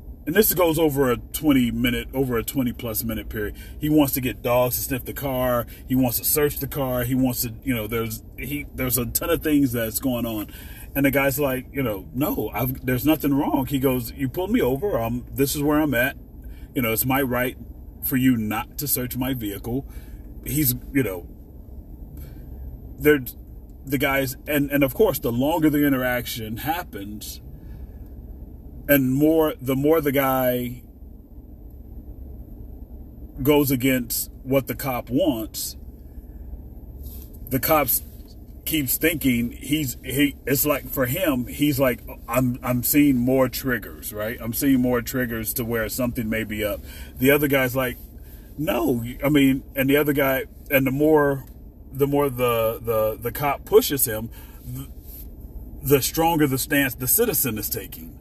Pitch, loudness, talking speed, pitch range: 125 Hz, -22 LUFS, 165 wpm, 105-140 Hz